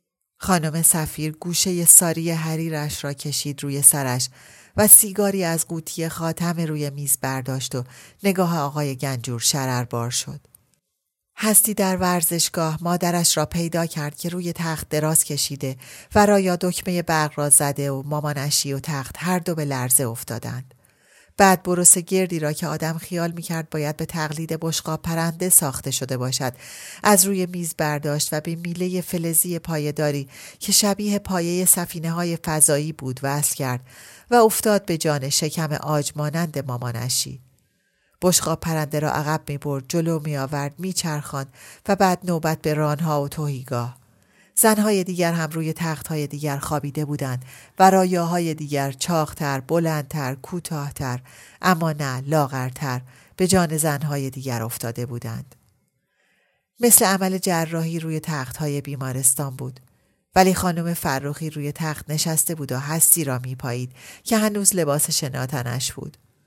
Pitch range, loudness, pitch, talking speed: 140-170 Hz, -20 LUFS, 155 Hz, 140 wpm